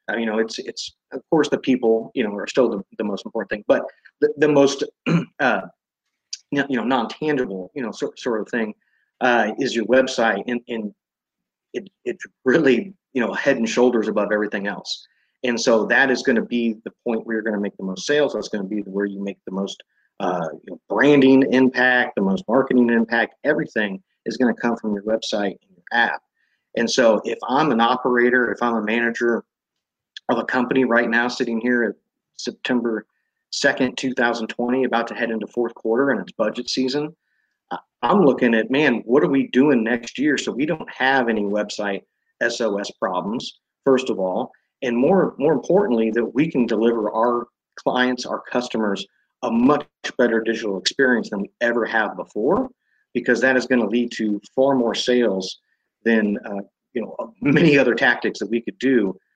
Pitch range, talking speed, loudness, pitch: 110-130 Hz, 195 wpm, -20 LUFS, 120 Hz